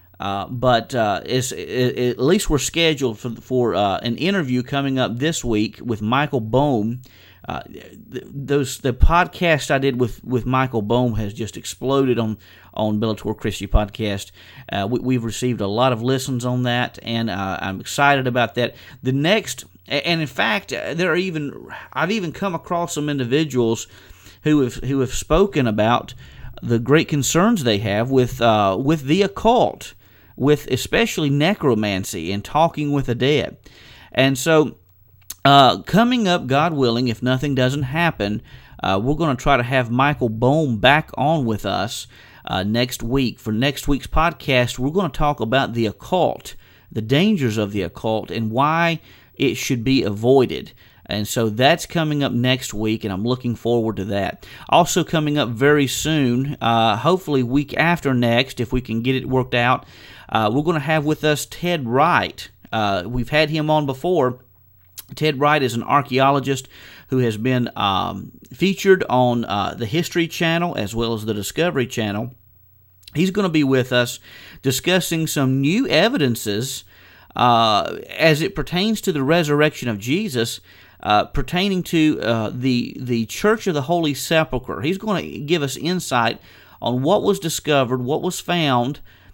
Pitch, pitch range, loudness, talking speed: 130 Hz, 115-150 Hz, -19 LUFS, 170 wpm